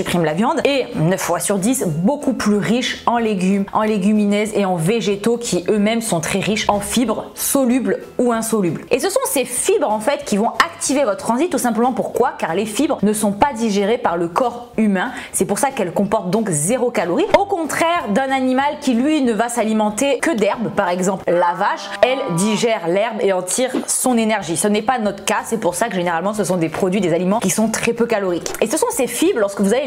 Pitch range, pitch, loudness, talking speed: 200-255 Hz, 220 Hz, -18 LUFS, 230 wpm